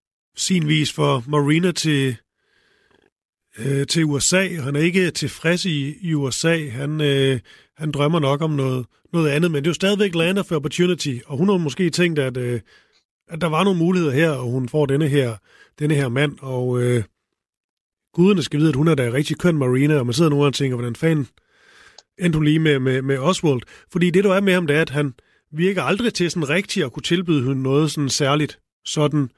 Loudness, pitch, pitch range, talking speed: -20 LUFS, 150 Hz, 140-170 Hz, 210 wpm